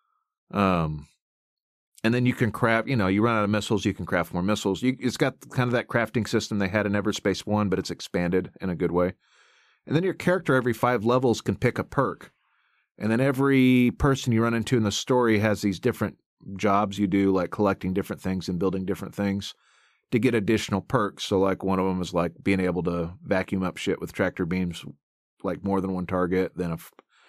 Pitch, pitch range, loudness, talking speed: 100 Hz, 95-120 Hz, -25 LUFS, 220 wpm